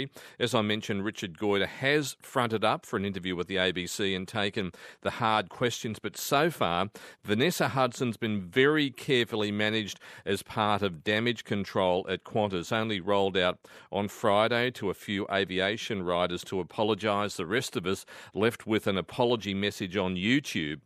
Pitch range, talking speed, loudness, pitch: 95-115 Hz, 165 wpm, -29 LUFS, 105 Hz